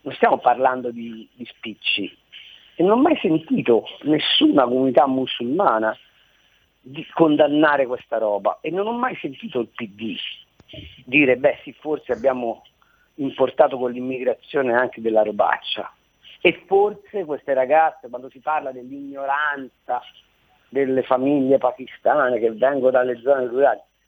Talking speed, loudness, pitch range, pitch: 130 wpm, -20 LUFS, 125-150 Hz, 130 Hz